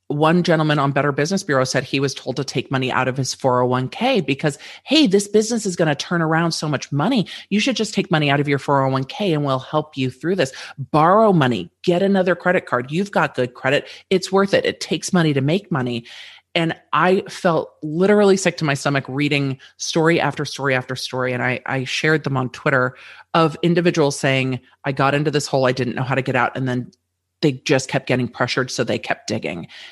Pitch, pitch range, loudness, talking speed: 145 Hz, 130-175 Hz, -19 LUFS, 220 wpm